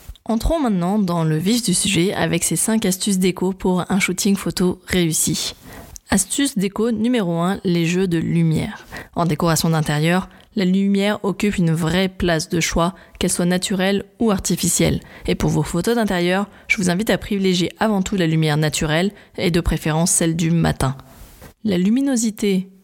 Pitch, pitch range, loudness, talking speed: 185 Hz, 170-200 Hz, -19 LUFS, 170 wpm